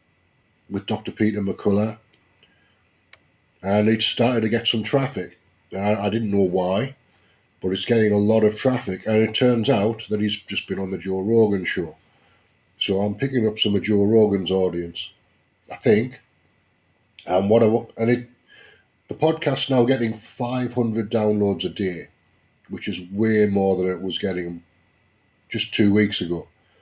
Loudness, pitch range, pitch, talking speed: -22 LUFS, 95-115 Hz, 105 Hz, 160 wpm